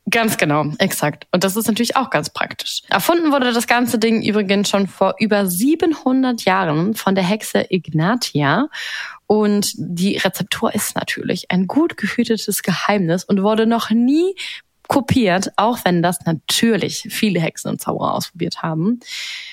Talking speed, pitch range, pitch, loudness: 150 wpm, 185-235 Hz, 210 Hz, -18 LUFS